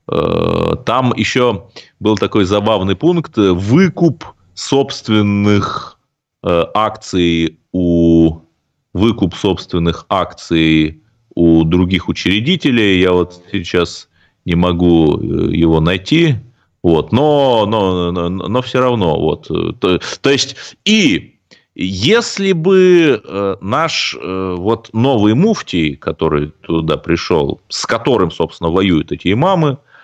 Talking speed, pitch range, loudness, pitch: 100 wpm, 85-135 Hz, -14 LUFS, 100 Hz